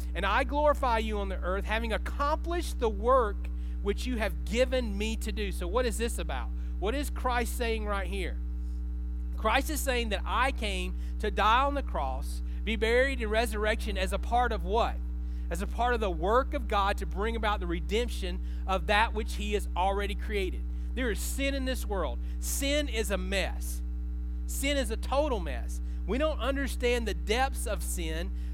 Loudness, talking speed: -30 LUFS, 190 wpm